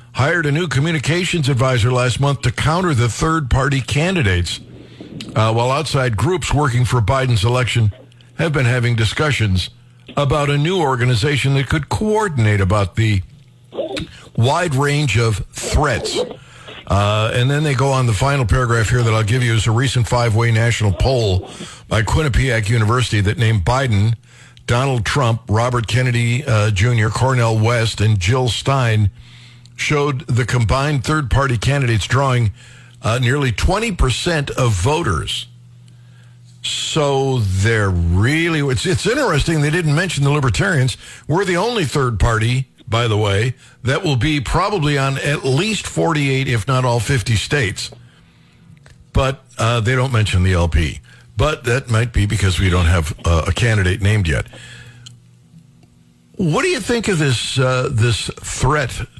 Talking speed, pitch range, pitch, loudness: 150 wpm, 110-140 Hz, 125 Hz, -17 LUFS